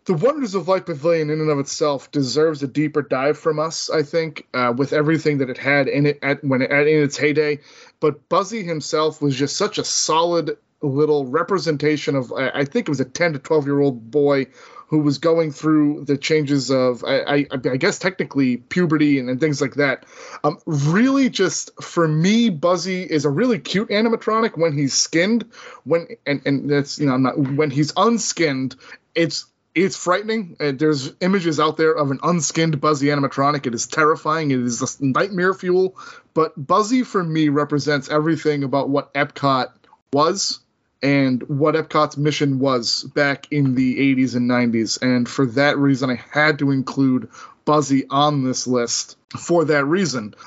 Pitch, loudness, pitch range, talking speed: 150 Hz, -19 LUFS, 140-165 Hz, 180 wpm